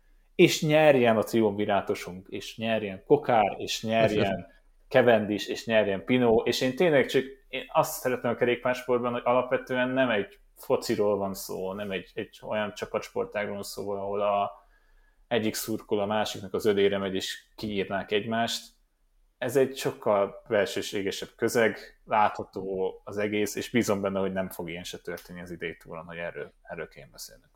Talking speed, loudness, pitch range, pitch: 155 wpm, -27 LUFS, 100-120 Hz, 105 Hz